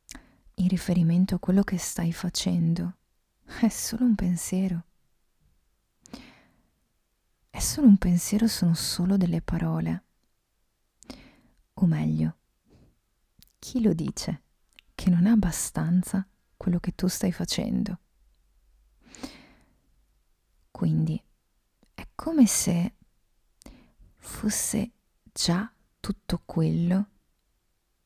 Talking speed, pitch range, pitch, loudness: 90 wpm, 165-195 Hz, 180 Hz, -26 LUFS